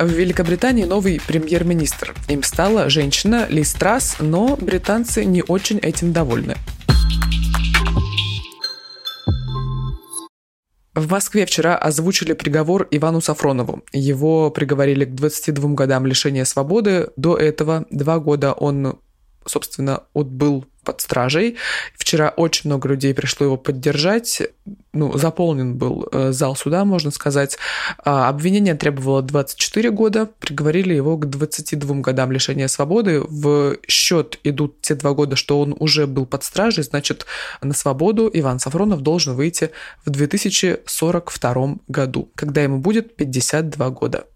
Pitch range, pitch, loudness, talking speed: 140-175 Hz, 150 Hz, -18 LUFS, 120 wpm